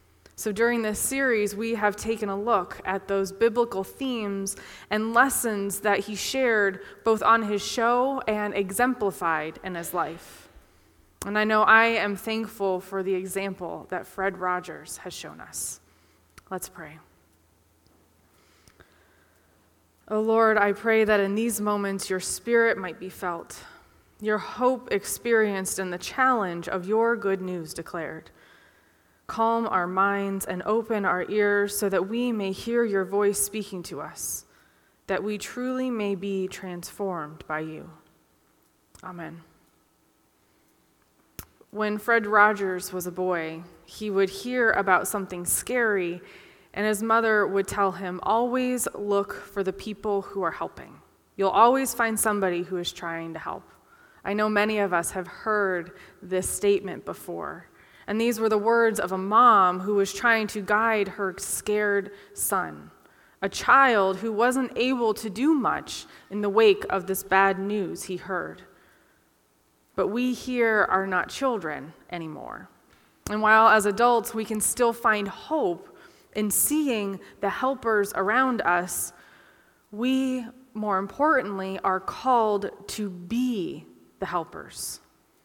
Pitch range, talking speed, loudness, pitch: 185-225 Hz, 145 wpm, -25 LUFS, 205 Hz